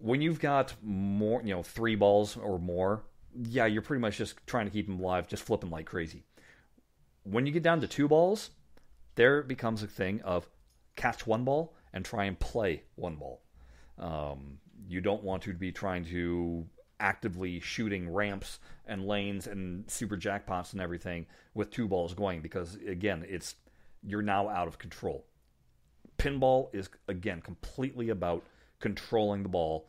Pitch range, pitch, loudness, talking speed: 90-115 Hz, 100 Hz, -33 LUFS, 165 wpm